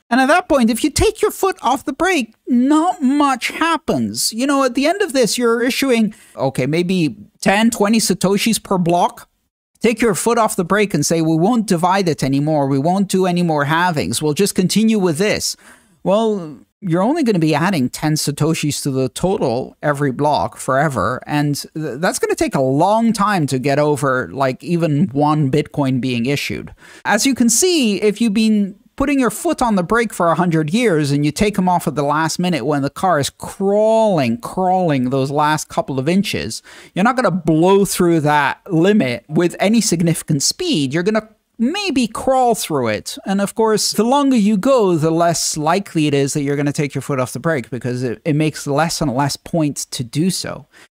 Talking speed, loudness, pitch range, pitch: 205 wpm, -16 LUFS, 150-225 Hz, 180 Hz